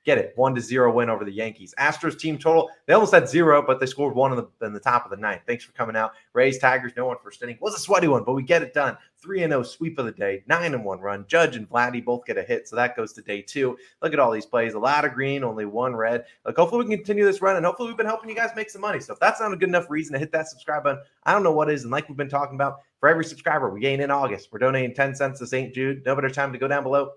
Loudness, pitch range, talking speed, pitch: -23 LUFS, 125-165 Hz, 320 wpm, 140 Hz